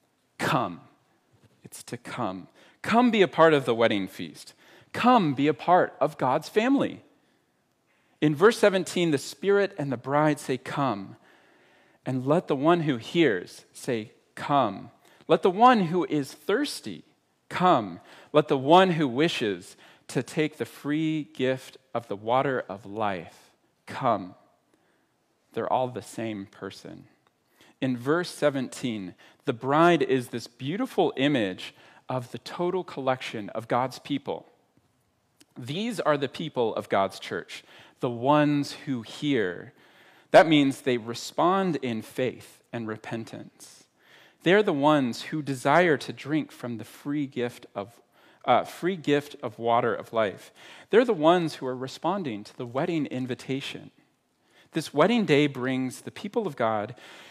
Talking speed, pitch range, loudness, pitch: 145 wpm, 125-160 Hz, -26 LUFS, 140 Hz